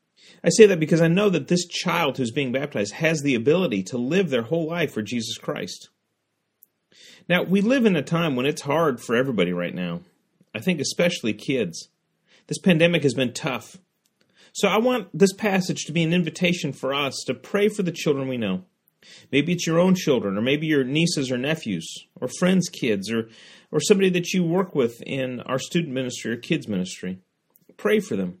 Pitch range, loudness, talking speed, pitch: 130-180 Hz, -23 LUFS, 200 wpm, 160 Hz